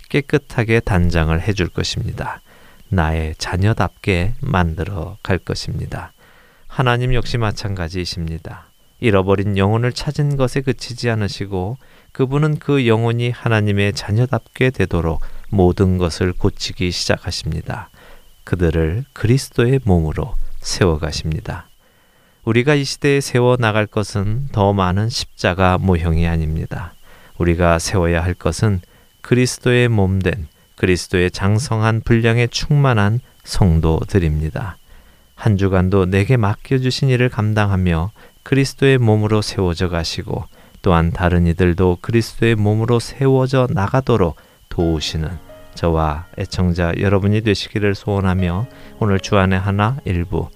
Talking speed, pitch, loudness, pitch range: 295 characters per minute, 100 Hz, -18 LUFS, 90-120 Hz